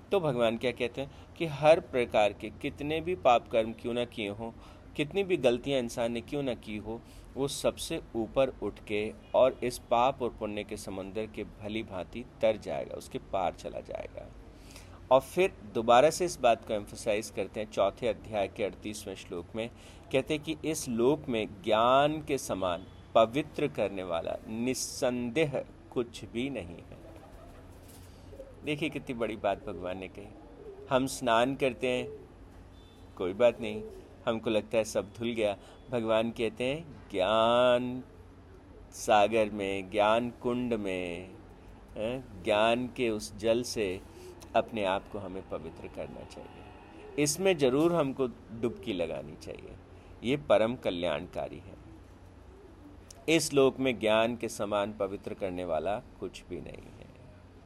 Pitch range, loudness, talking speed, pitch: 95-125 Hz, -31 LUFS, 150 wpm, 110 Hz